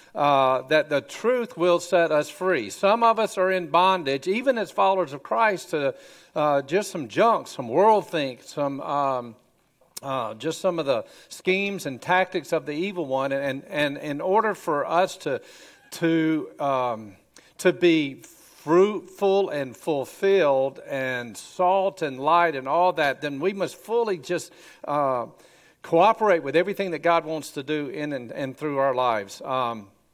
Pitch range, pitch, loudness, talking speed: 140-185 Hz, 160 Hz, -24 LUFS, 165 wpm